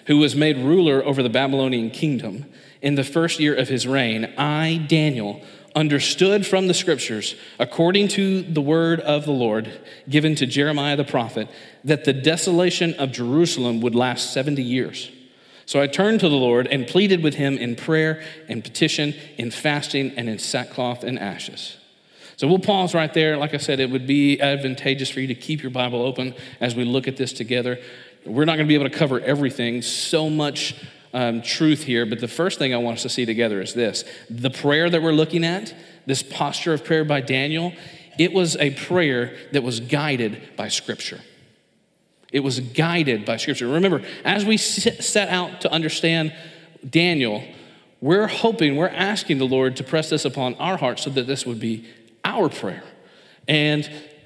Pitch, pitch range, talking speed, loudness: 145 Hz, 125-160 Hz, 185 wpm, -21 LUFS